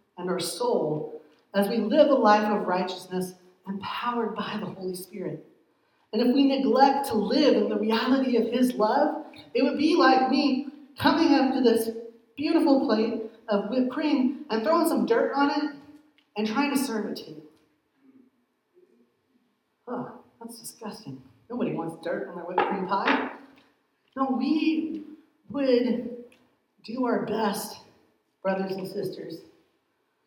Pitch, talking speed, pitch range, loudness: 240 Hz, 145 wpm, 210-280 Hz, -25 LUFS